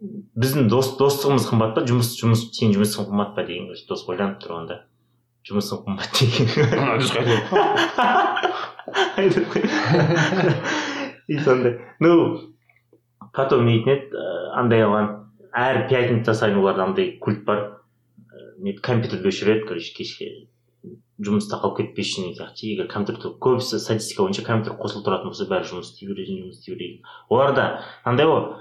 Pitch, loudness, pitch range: 125 Hz, -21 LUFS, 110-165 Hz